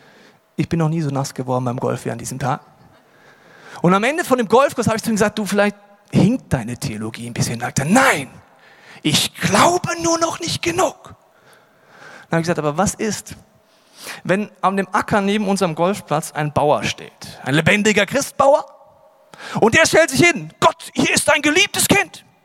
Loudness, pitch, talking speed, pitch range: -18 LUFS, 205 Hz, 190 wpm, 160-260 Hz